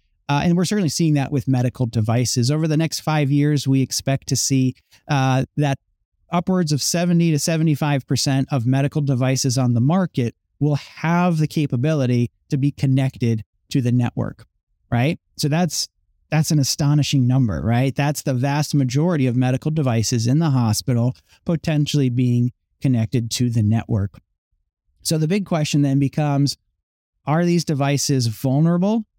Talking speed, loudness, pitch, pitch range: 155 wpm, -20 LUFS, 135 Hz, 125-155 Hz